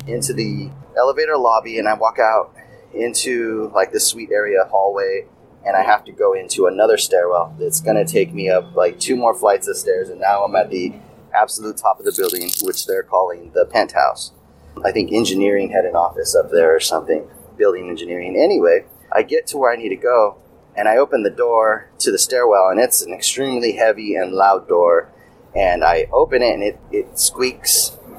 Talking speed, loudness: 200 wpm, -17 LUFS